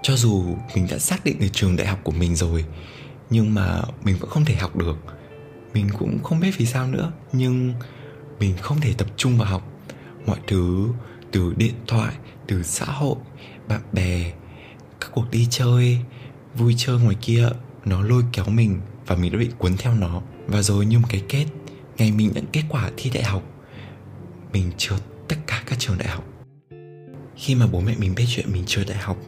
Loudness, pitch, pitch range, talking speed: -22 LUFS, 115 Hz, 95-130 Hz, 200 wpm